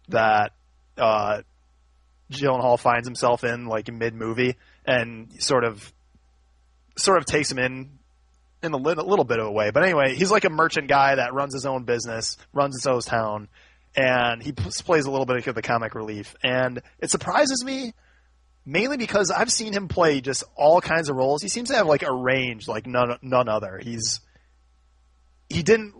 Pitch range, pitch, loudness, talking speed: 105-140 Hz, 125 Hz, -23 LUFS, 185 wpm